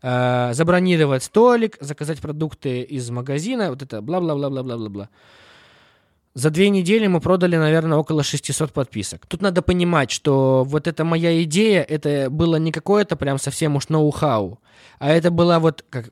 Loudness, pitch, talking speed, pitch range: -19 LUFS, 155 Hz, 165 wpm, 135-170 Hz